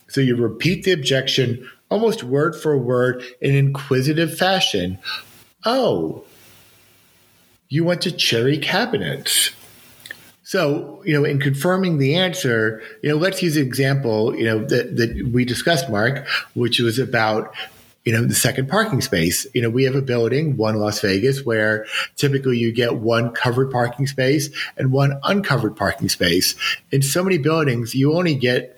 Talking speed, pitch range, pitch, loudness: 160 wpm, 115-150 Hz, 135 Hz, -19 LUFS